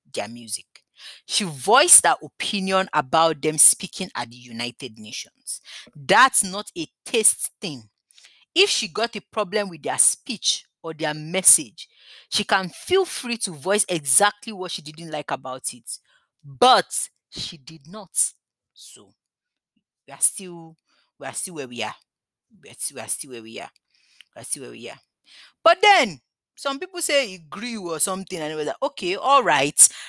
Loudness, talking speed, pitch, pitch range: -20 LUFS, 165 wpm, 180 Hz, 150-215 Hz